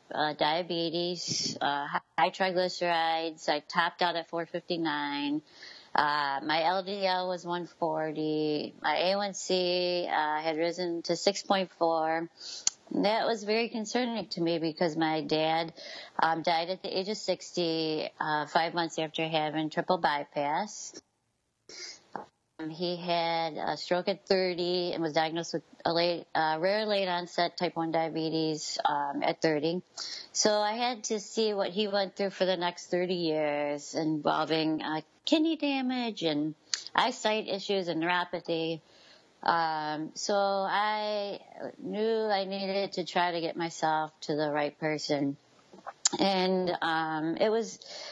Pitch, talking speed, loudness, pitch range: 170 Hz, 135 wpm, -30 LUFS, 160-195 Hz